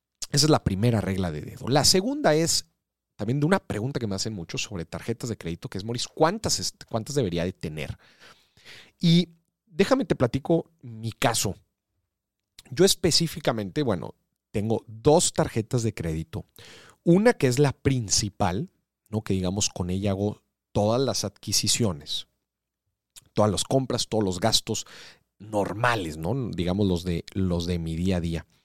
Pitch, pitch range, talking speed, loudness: 110 Hz, 95-140 Hz, 155 wpm, -25 LUFS